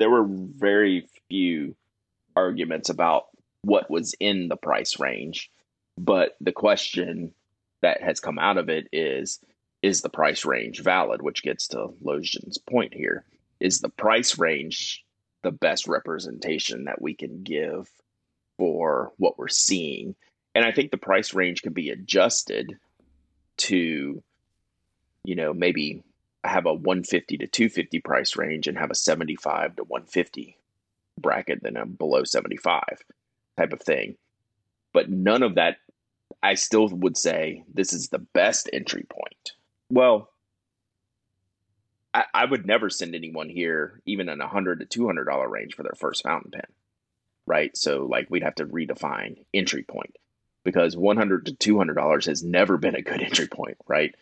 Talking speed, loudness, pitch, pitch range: 160 wpm, -24 LUFS, 100 Hz, 90-110 Hz